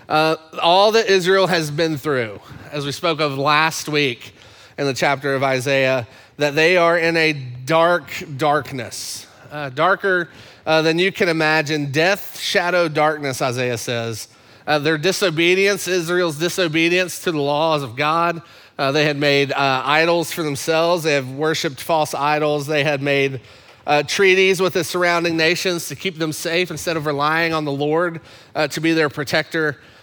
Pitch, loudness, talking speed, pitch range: 155 Hz, -18 LUFS, 170 wpm, 140-170 Hz